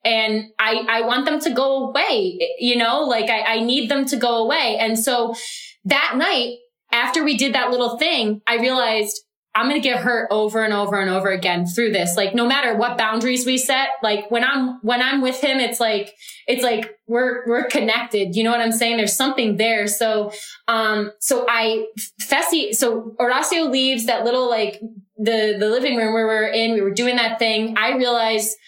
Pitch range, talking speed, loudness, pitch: 220-255 Hz, 205 wpm, -19 LUFS, 230 Hz